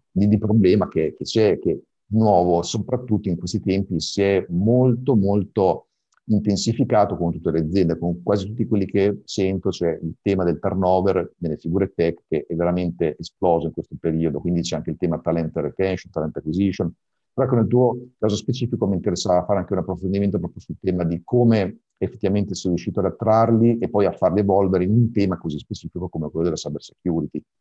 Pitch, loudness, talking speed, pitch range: 95 Hz, -21 LUFS, 190 wpm, 85-105 Hz